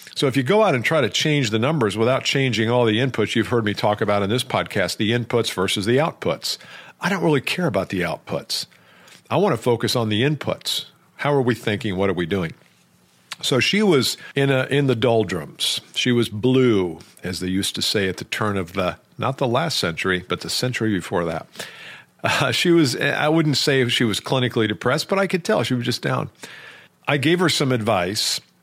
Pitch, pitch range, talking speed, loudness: 120 Hz, 105-140 Hz, 220 wpm, -21 LUFS